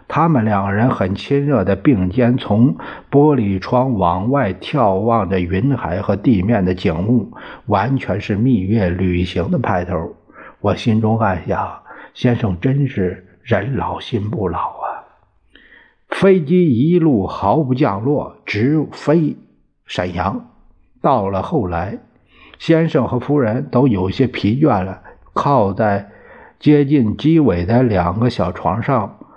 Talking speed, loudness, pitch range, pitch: 185 characters per minute, -17 LUFS, 100-140 Hz, 115 Hz